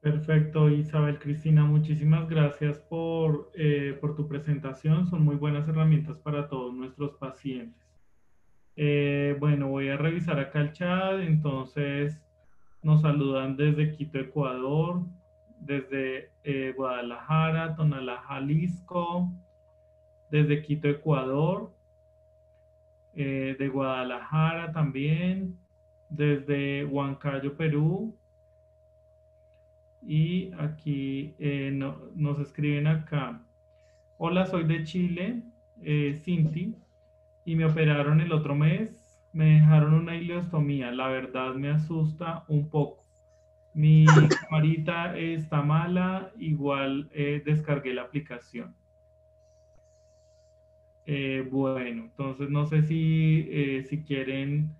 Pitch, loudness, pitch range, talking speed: 145 Hz, -27 LUFS, 130-155 Hz, 105 wpm